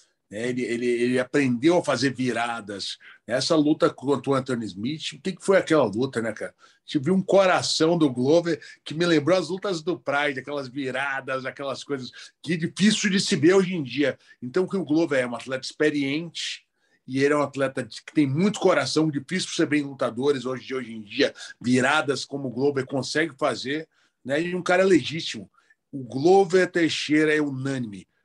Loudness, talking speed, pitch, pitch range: -24 LUFS, 185 wpm, 145 Hz, 130-170 Hz